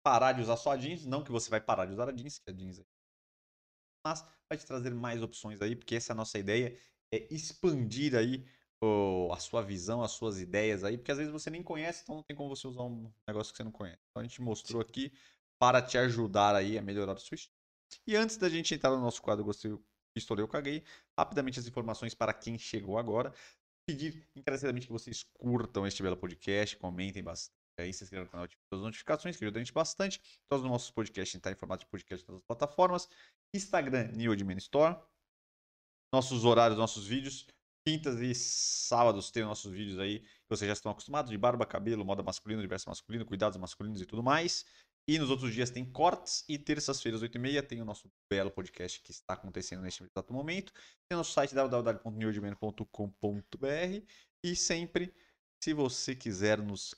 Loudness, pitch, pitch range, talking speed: -35 LUFS, 115 Hz, 100-135 Hz, 215 wpm